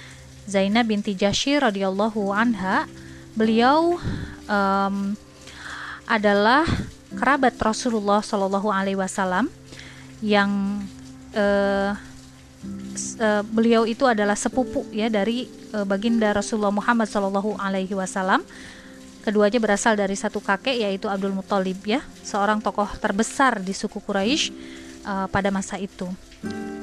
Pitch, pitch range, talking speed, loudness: 205 Hz, 195-225 Hz, 105 wpm, -22 LUFS